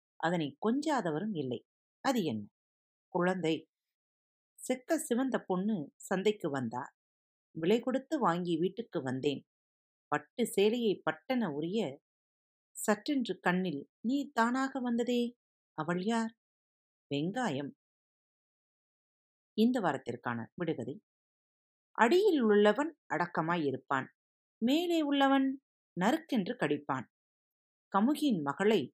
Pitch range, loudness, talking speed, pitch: 150-245 Hz, -33 LUFS, 85 wpm, 205 Hz